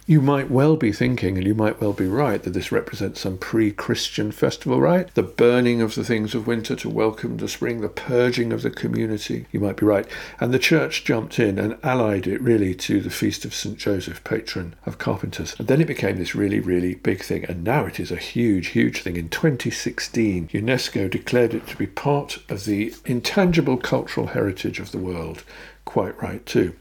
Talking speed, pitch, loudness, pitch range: 210 wpm, 115 Hz, -22 LUFS, 100-130 Hz